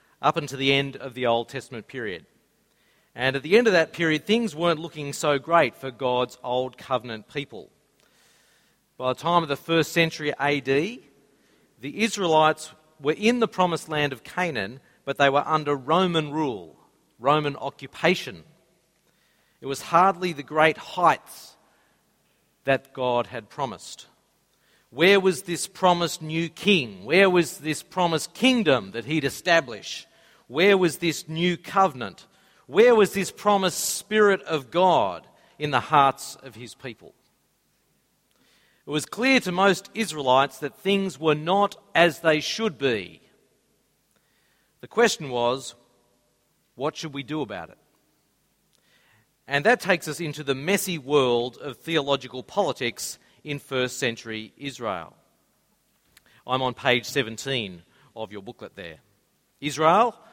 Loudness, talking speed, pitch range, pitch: -24 LUFS, 140 wpm, 135-180 Hz, 155 Hz